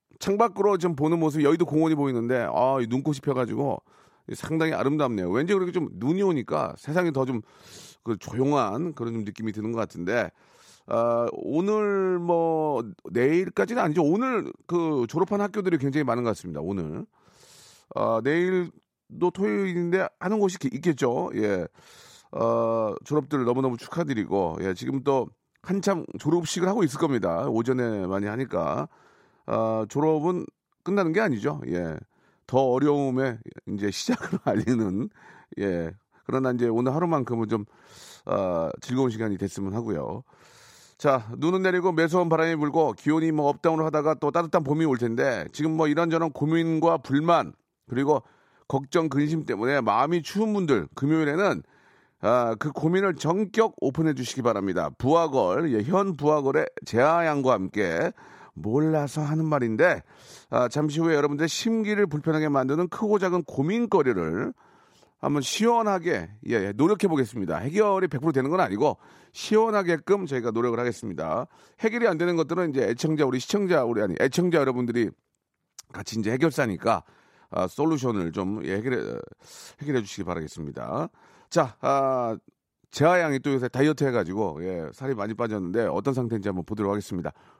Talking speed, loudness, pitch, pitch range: 335 characters per minute, -25 LUFS, 145 Hz, 120-170 Hz